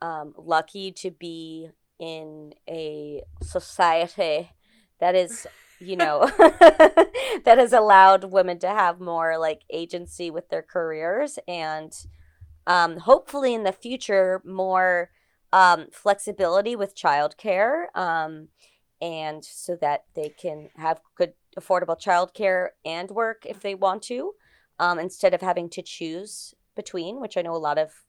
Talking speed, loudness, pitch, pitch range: 135 wpm, -21 LUFS, 180 Hz, 165-205 Hz